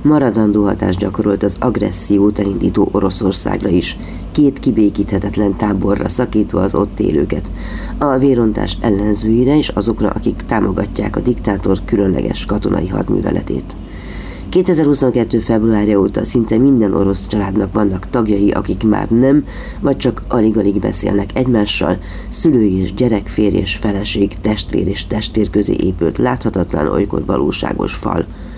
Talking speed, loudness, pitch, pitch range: 120 wpm, -15 LUFS, 105 Hz, 100-115 Hz